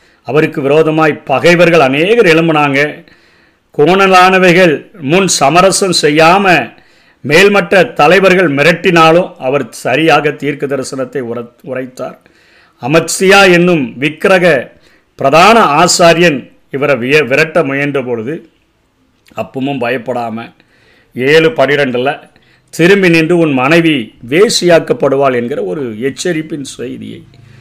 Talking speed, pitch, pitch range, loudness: 85 wpm, 160 Hz, 140-175 Hz, -9 LUFS